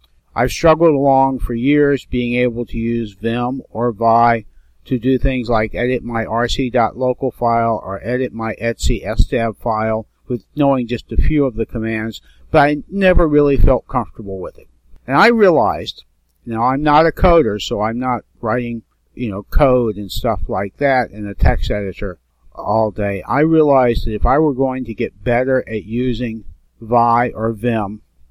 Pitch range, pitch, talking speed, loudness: 105-130 Hz, 115 Hz, 170 wpm, -17 LUFS